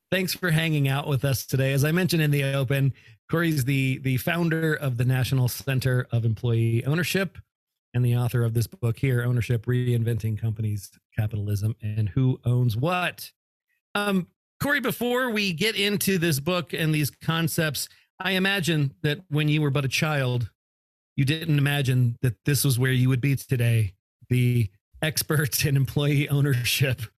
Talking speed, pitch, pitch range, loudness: 165 wpm, 135 Hz, 120-155 Hz, -24 LUFS